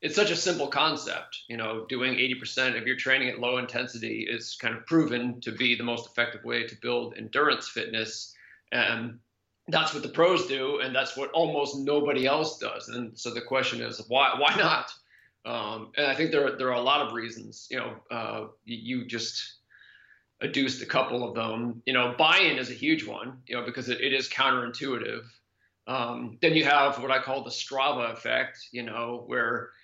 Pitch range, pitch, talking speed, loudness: 115-135 Hz, 125 Hz, 200 wpm, -27 LUFS